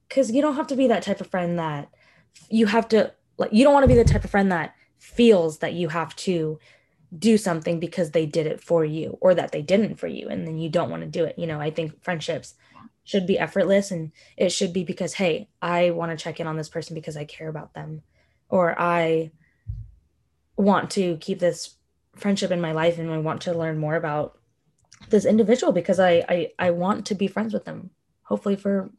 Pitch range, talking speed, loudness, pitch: 160-195 Hz, 230 wpm, -23 LUFS, 170 Hz